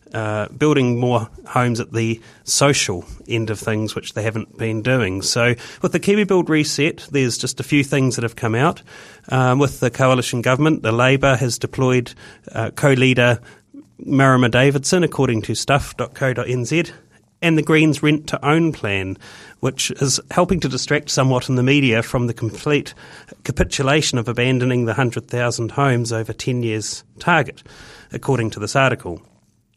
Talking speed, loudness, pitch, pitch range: 160 wpm, -18 LUFS, 130 Hz, 115-140 Hz